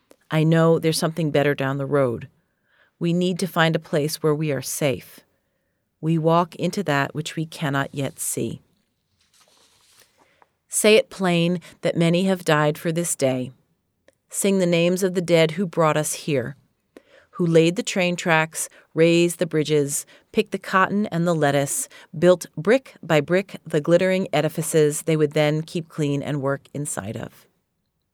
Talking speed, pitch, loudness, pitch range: 165 wpm, 165 Hz, -21 LUFS, 150-175 Hz